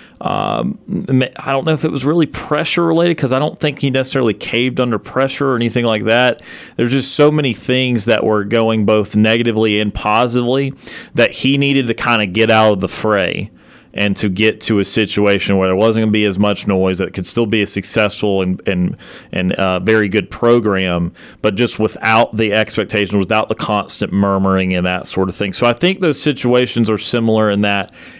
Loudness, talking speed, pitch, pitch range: -14 LUFS, 210 wpm, 110 Hz, 100-125 Hz